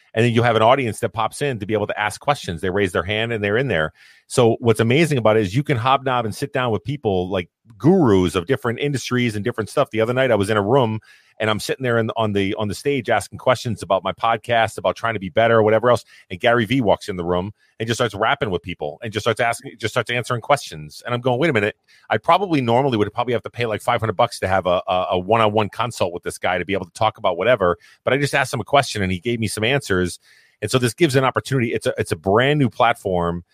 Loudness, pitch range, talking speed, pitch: -20 LUFS, 105-125 Hz, 280 wpm, 115 Hz